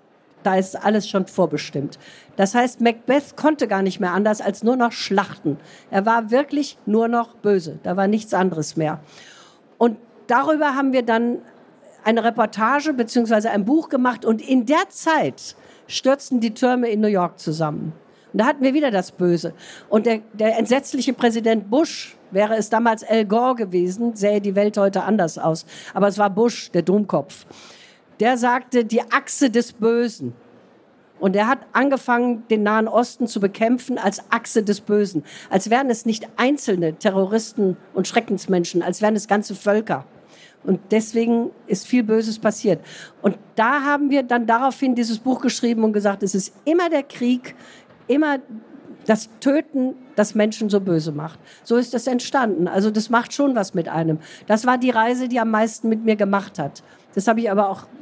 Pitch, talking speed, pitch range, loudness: 220 Hz, 175 wpm, 195-245 Hz, -20 LUFS